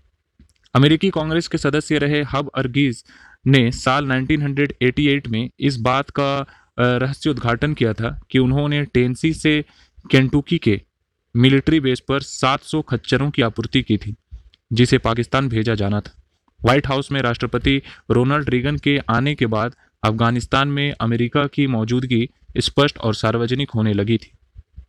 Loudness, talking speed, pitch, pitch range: -19 LUFS, 140 wpm, 130 Hz, 115-145 Hz